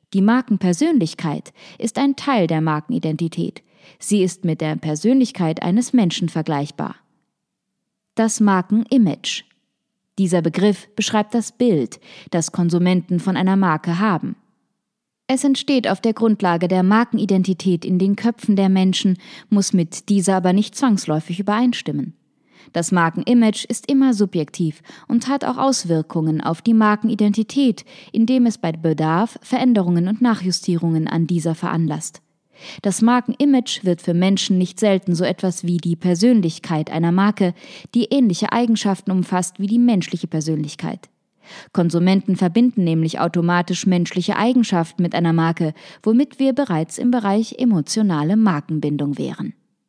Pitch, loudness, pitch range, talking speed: 190 Hz, -19 LUFS, 170-225 Hz, 130 wpm